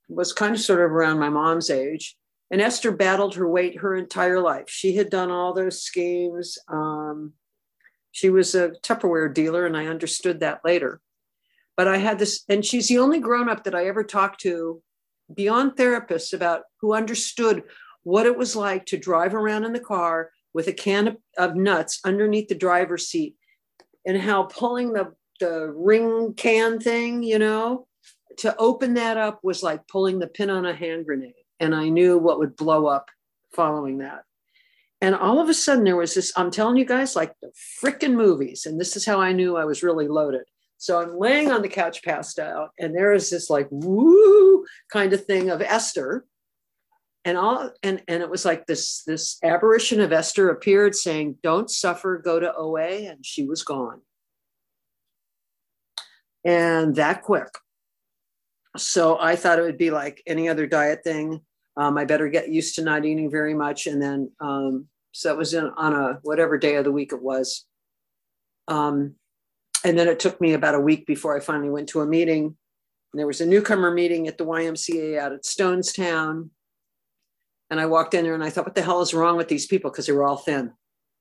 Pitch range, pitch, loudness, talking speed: 160-205 Hz, 175 Hz, -22 LUFS, 195 wpm